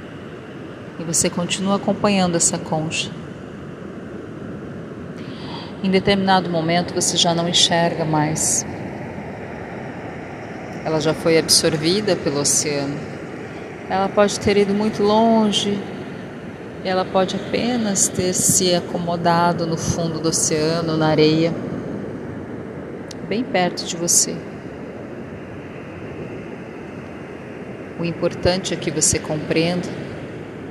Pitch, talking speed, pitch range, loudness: 175 Hz, 95 wpm, 165-190 Hz, -19 LUFS